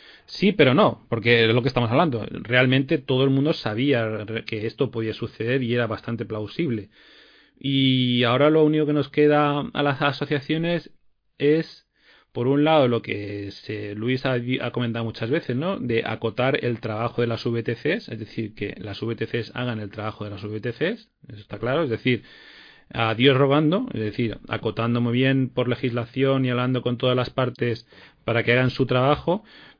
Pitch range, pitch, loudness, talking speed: 115-140 Hz, 125 Hz, -23 LUFS, 175 wpm